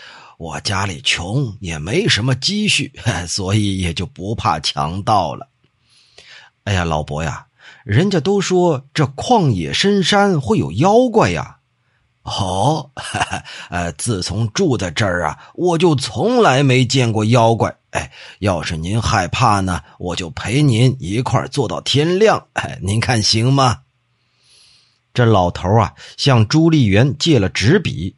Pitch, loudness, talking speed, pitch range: 120 Hz, -16 LUFS, 195 characters per minute, 100-140 Hz